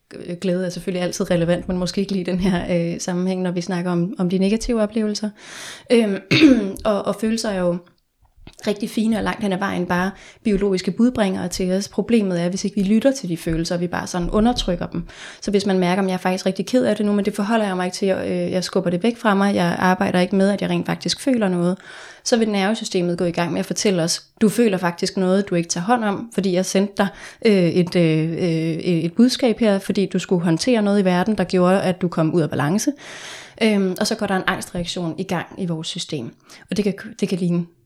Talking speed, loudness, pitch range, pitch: 240 wpm, -20 LUFS, 180-210 Hz, 190 Hz